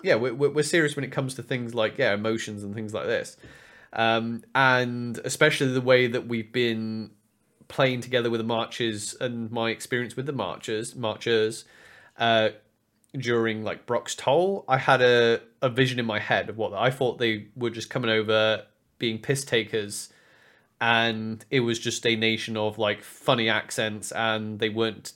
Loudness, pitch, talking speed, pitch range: -25 LUFS, 115 Hz, 180 wpm, 110-125 Hz